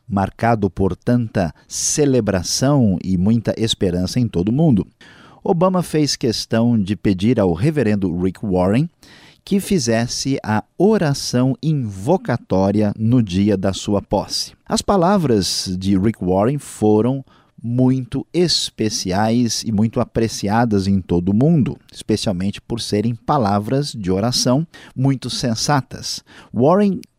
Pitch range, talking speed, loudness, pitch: 100-135 Hz, 120 wpm, -18 LUFS, 115 Hz